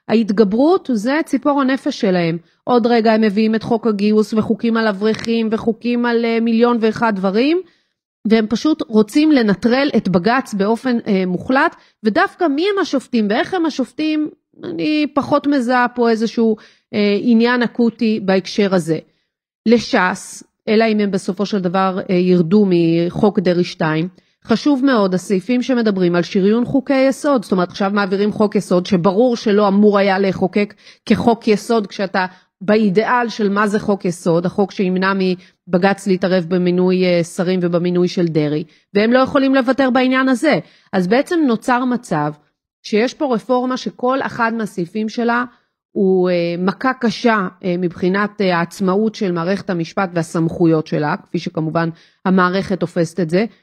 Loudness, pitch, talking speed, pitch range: -16 LUFS, 215 Hz, 140 wpm, 185-245 Hz